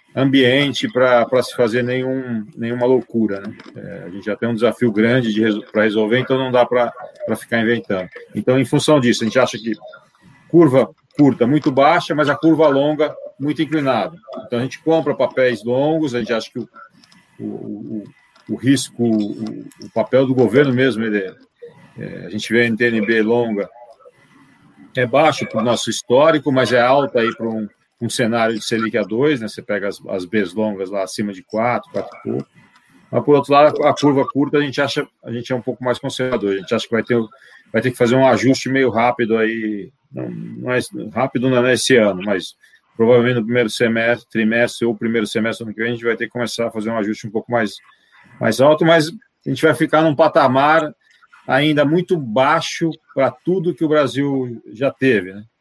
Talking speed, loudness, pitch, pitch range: 205 wpm, -17 LUFS, 125 Hz, 115-140 Hz